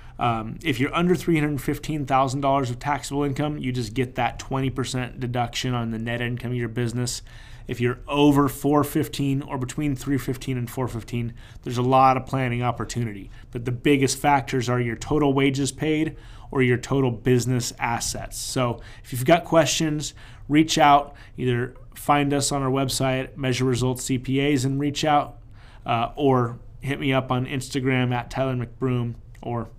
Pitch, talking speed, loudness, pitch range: 130 Hz, 160 wpm, -23 LUFS, 120-140 Hz